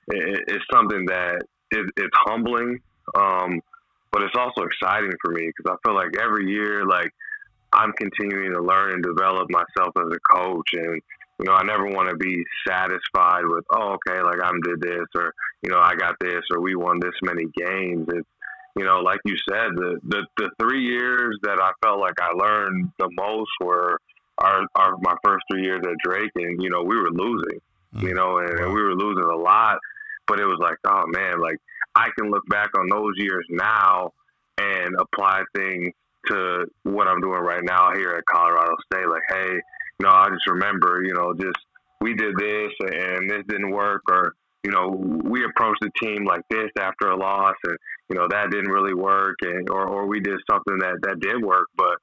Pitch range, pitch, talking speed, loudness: 90-105 Hz, 95 Hz, 205 wpm, -22 LUFS